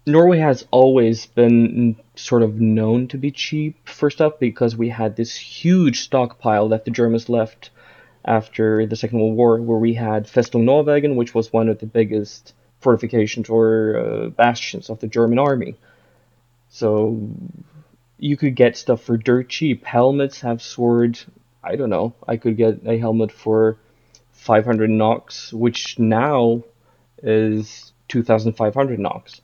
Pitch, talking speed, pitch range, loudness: 115 Hz, 150 wpm, 110-125 Hz, -18 LUFS